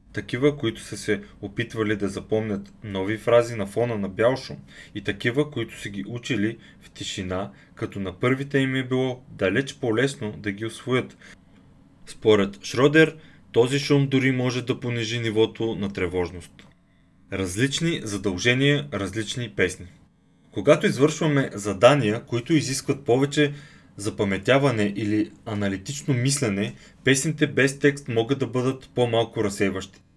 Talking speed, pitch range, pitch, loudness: 130 wpm, 100-135 Hz, 115 Hz, -24 LUFS